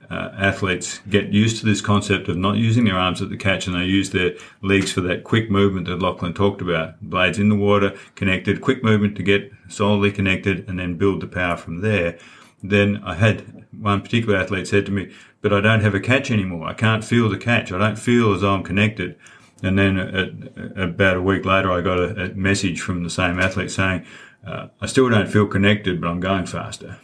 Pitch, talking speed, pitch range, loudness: 100 Hz, 225 wpm, 90-105 Hz, -20 LUFS